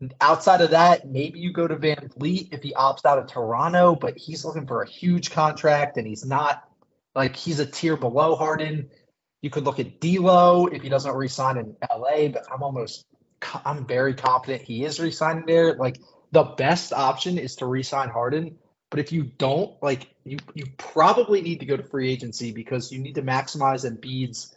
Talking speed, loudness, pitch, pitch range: 200 wpm, -23 LUFS, 145 Hz, 130-160 Hz